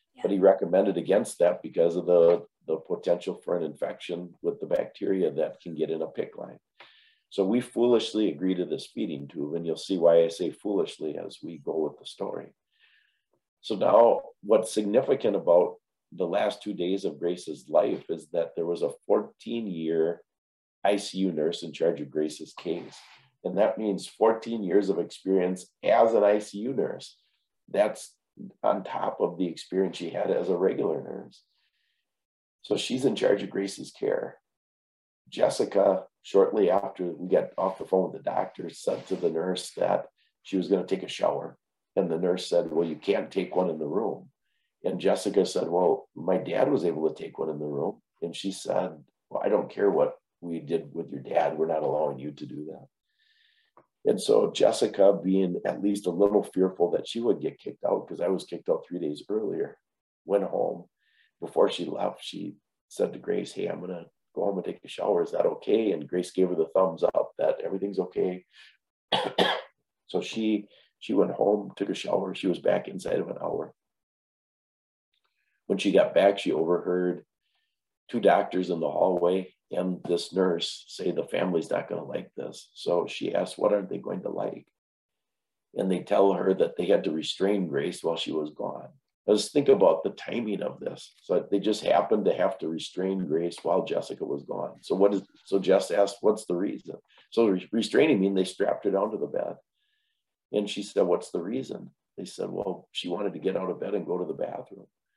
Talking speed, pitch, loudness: 195 wpm, 110 Hz, -27 LUFS